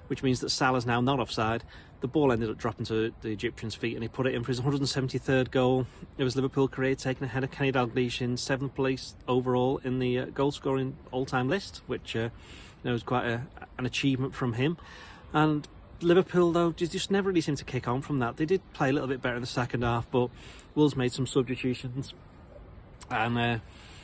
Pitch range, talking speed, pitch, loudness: 120-140 Hz, 210 wpm, 130 Hz, -29 LUFS